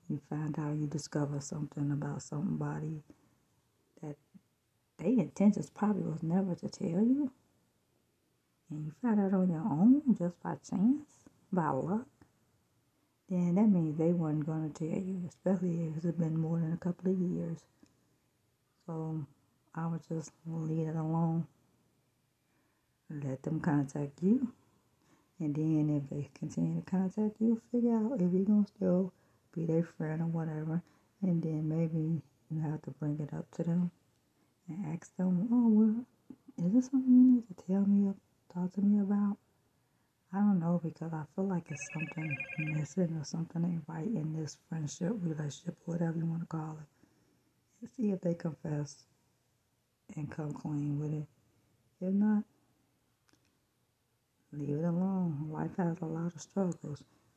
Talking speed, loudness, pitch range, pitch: 160 wpm, -34 LUFS, 150-190 Hz, 165 Hz